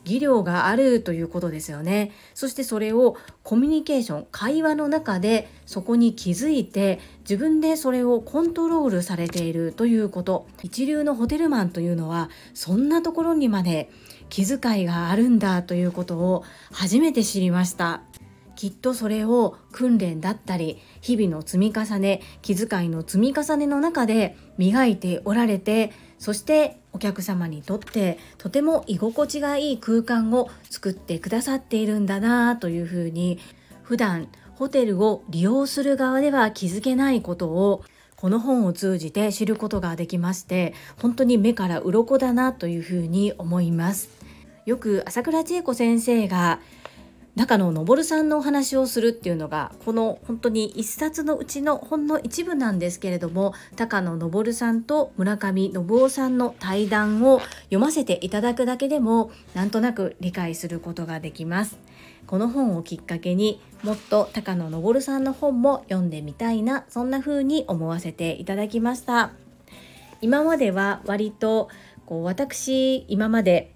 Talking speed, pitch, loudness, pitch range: 320 characters per minute, 215 Hz, -23 LUFS, 180-255 Hz